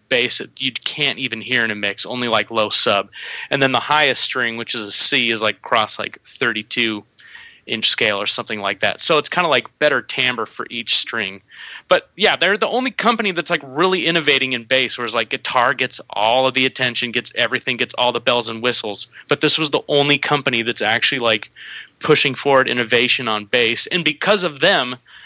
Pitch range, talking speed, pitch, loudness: 115-145 Hz, 210 wpm, 125 Hz, -16 LUFS